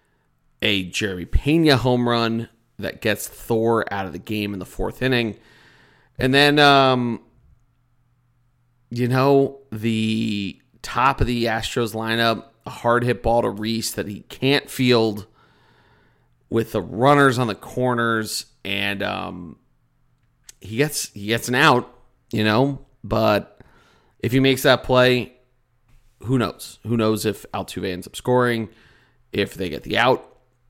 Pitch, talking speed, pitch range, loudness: 120 Hz, 145 wpm, 110-125 Hz, -20 LUFS